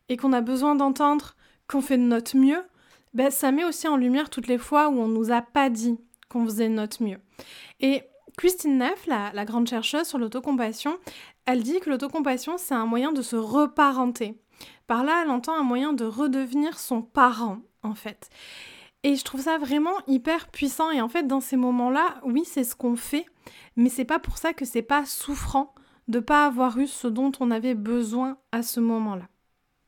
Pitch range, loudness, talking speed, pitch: 235-290 Hz, -25 LUFS, 200 wpm, 265 Hz